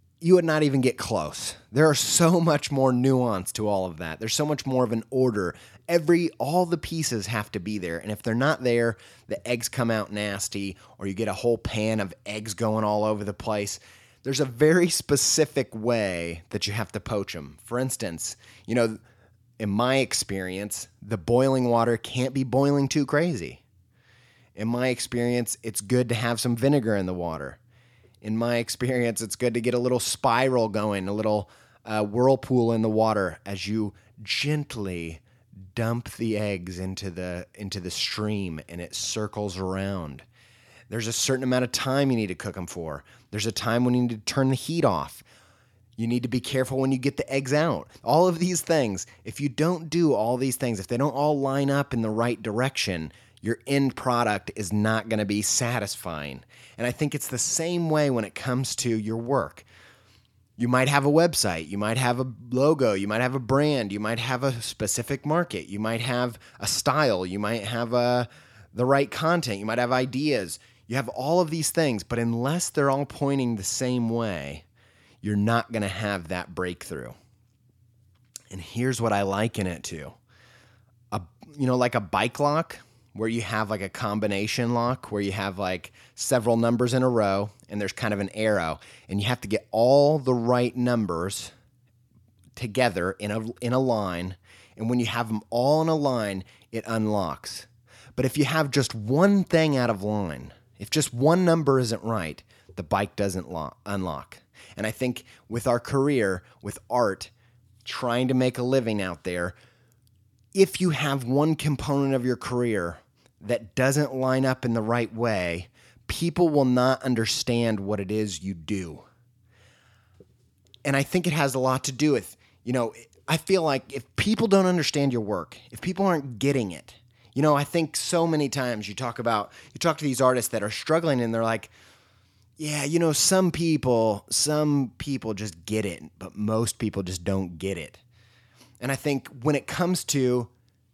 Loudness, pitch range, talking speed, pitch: -25 LUFS, 105-130 Hz, 190 wpm, 120 Hz